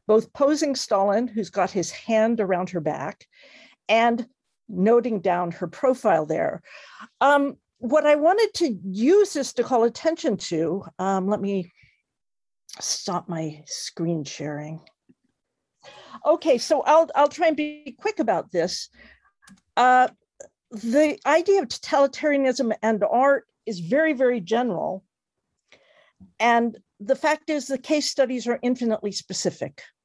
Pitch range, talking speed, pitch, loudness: 195-285 Hz, 130 wpm, 235 Hz, -23 LUFS